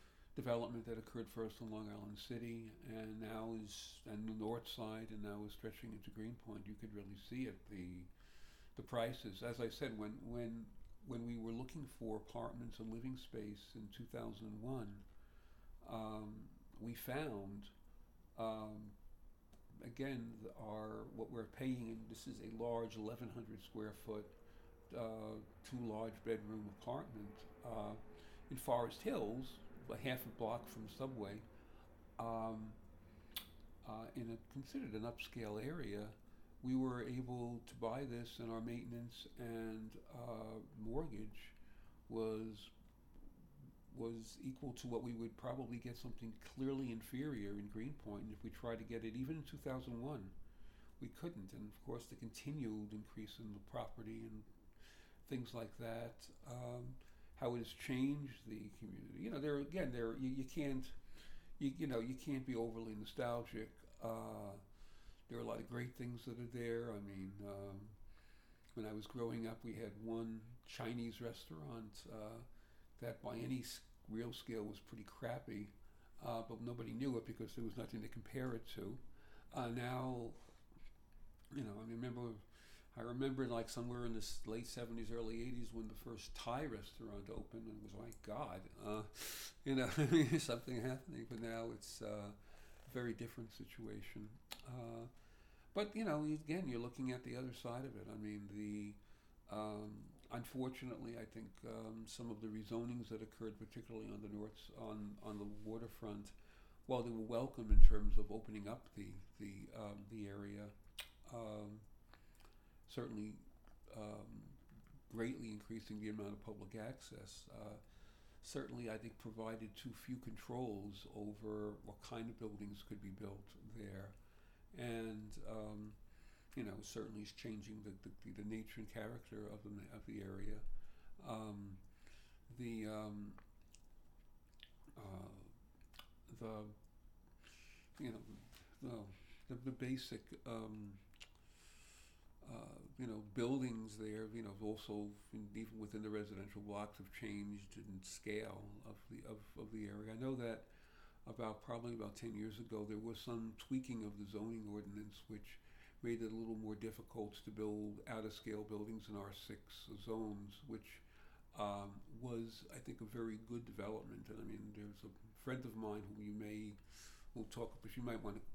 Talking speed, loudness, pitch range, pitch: 155 wpm, -49 LUFS, 105-120 Hz, 110 Hz